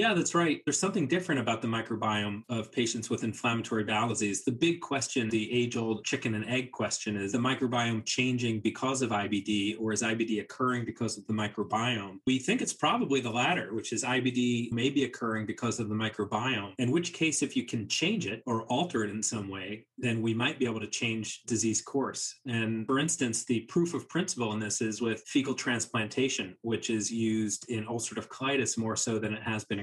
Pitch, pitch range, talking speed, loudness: 115 Hz, 110-130 Hz, 205 wpm, -30 LUFS